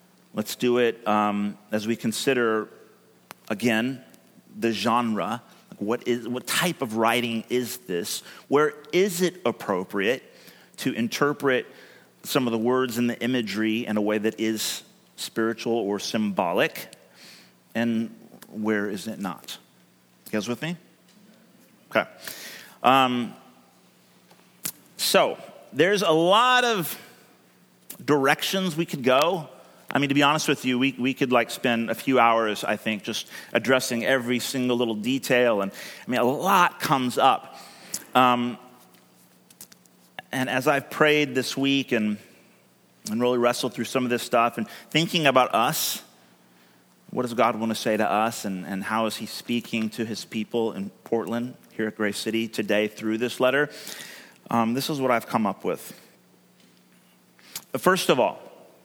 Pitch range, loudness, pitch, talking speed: 110-135 Hz, -24 LUFS, 120 Hz, 150 wpm